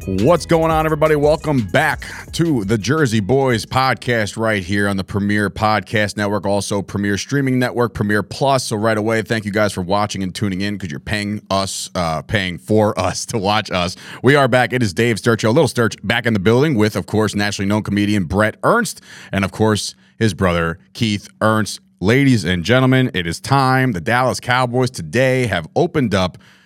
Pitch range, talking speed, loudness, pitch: 100-125 Hz, 200 wpm, -17 LUFS, 110 Hz